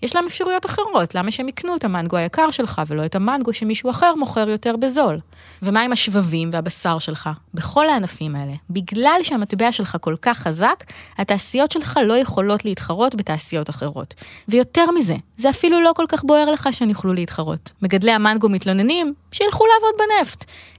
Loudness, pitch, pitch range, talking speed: -19 LUFS, 220 Hz, 175-290 Hz, 165 wpm